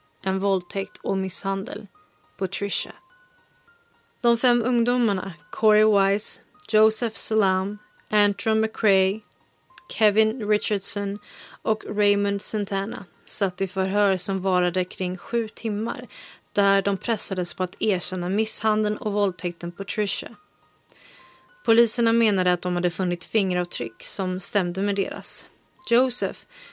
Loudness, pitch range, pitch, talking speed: -23 LUFS, 190-220 Hz, 205 Hz, 110 wpm